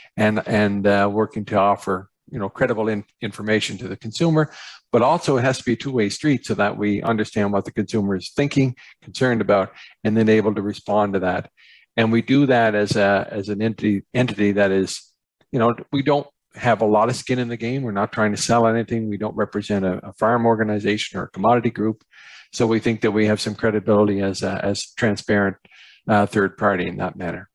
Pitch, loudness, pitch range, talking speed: 110 Hz, -21 LUFS, 100-115 Hz, 220 wpm